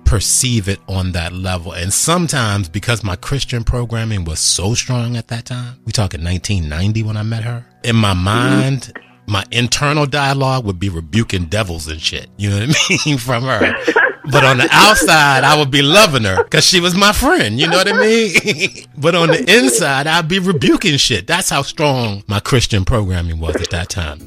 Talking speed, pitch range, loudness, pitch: 200 wpm, 100-145 Hz, -14 LUFS, 115 Hz